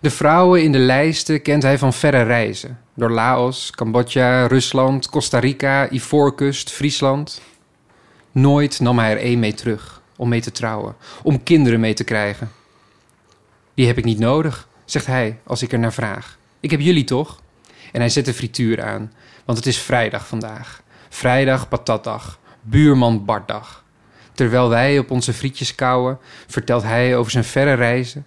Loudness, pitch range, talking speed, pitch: -17 LUFS, 115-135 Hz, 165 wpm, 125 Hz